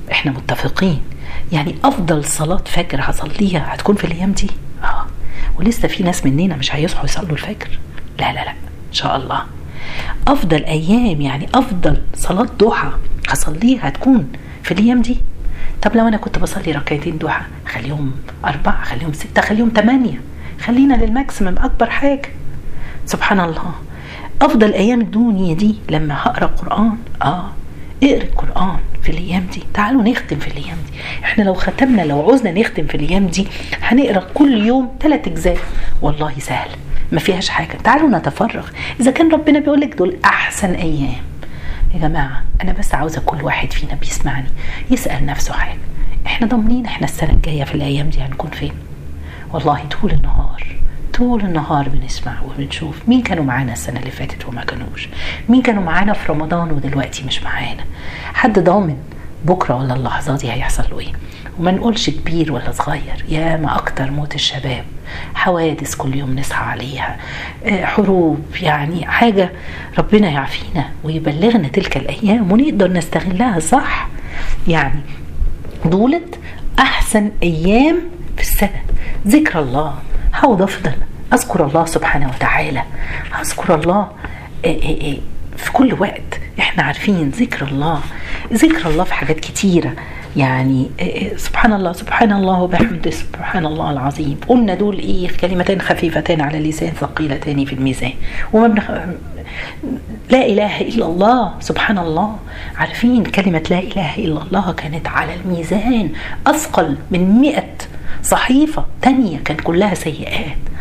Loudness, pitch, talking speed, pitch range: -16 LUFS, 170 Hz, 140 wpm, 140-215 Hz